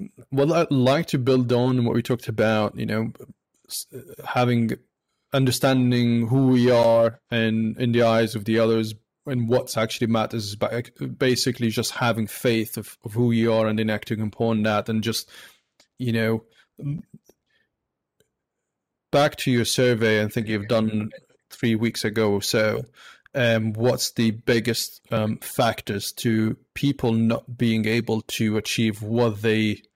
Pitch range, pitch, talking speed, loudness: 110-125 Hz, 115 Hz, 150 wpm, -23 LUFS